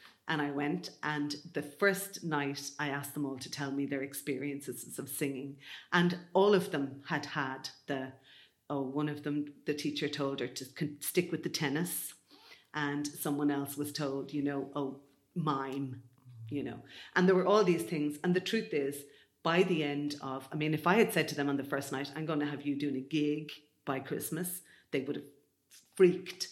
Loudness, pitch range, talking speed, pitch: -34 LUFS, 140-160 Hz, 200 wpm, 145 Hz